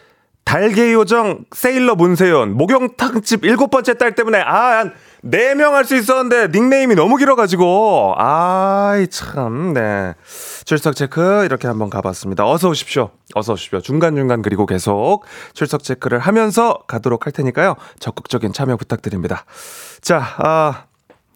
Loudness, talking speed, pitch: -15 LUFS, 310 characters per minute, 175 Hz